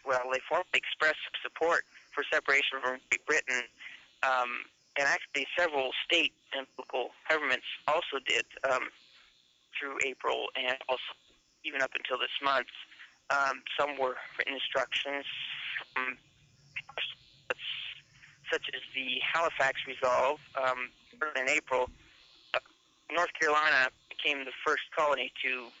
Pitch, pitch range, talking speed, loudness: 135 Hz, 130-150 Hz, 120 wpm, -31 LUFS